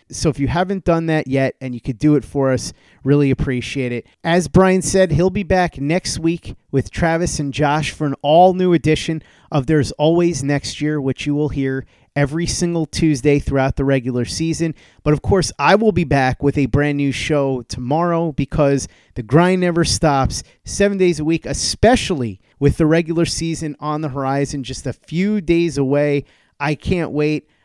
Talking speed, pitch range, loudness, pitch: 190 wpm, 135-165 Hz, -18 LUFS, 150 Hz